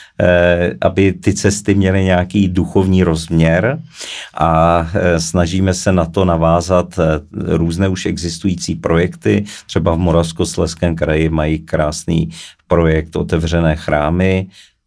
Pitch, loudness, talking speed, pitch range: 90 Hz, -15 LUFS, 105 wpm, 80-95 Hz